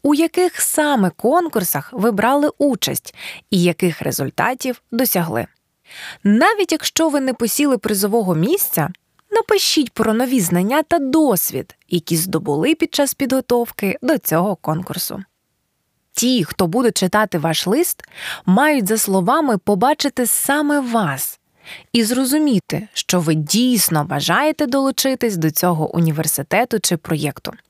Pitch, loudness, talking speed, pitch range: 225 Hz, -17 LUFS, 120 wpm, 175-275 Hz